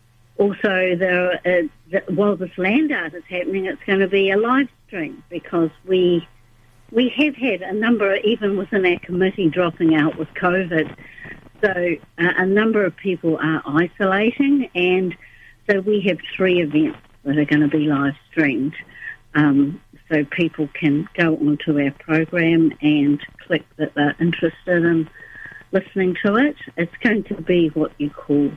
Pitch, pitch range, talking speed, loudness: 175 Hz, 150-195 Hz, 165 wpm, -19 LUFS